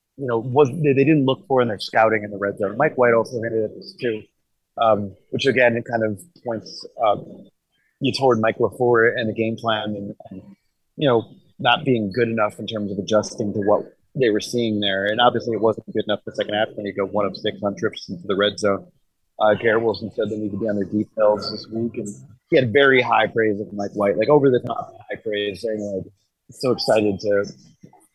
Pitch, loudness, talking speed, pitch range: 110 Hz, -21 LUFS, 240 wpm, 105-120 Hz